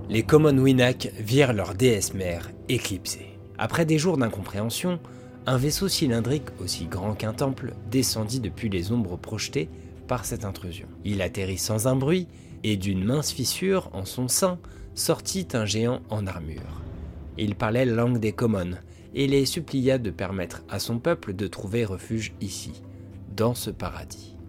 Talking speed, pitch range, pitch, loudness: 155 wpm, 95-125 Hz, 110 Hz, -26 LUFS